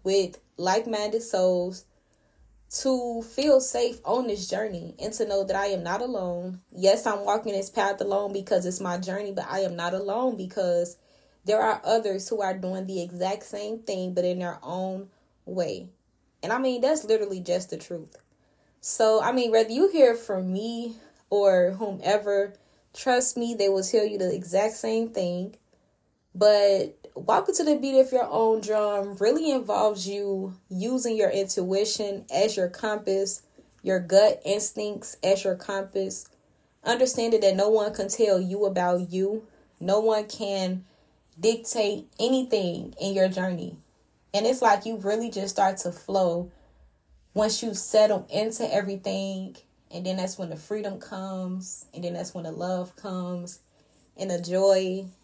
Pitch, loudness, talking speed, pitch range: 195 Hz, -25 LUFS, 160 wpm, 185-220 Hz